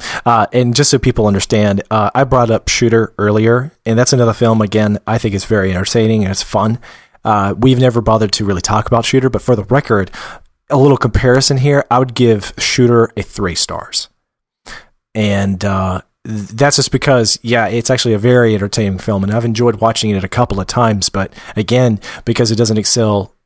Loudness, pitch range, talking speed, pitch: -13 LUFS, 105-125 Hz, 195 wpm, 115 Hz